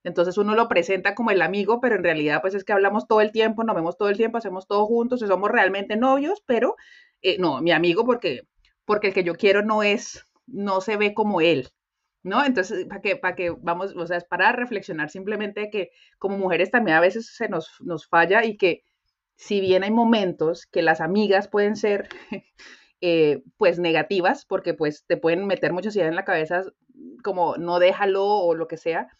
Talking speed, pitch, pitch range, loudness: 205 wpm, 195 Hz, 175-215 Hz, -22 LUFS